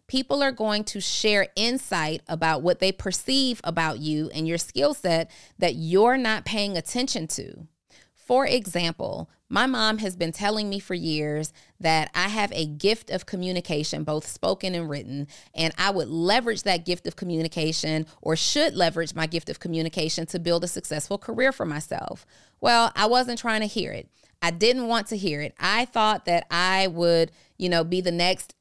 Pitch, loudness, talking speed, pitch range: 180 Hz, -25 LUFS, 185 wpm, 160-215 Hz